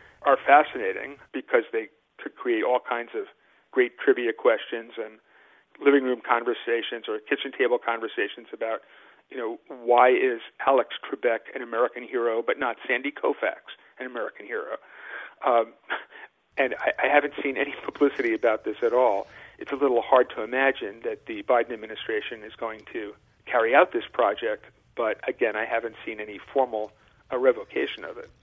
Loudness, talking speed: -25 LUFS, 165 wpm